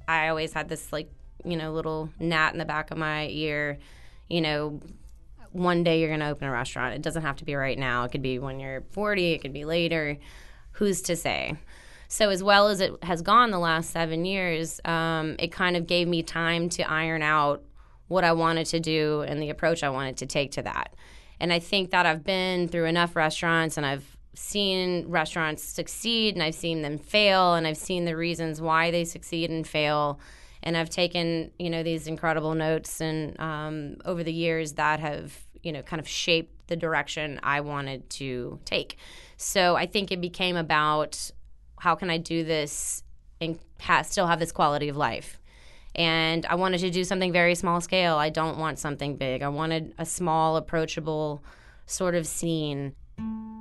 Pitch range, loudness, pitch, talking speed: 150-170 Hz, -26 LUFS, 160 Hz, 195 wpm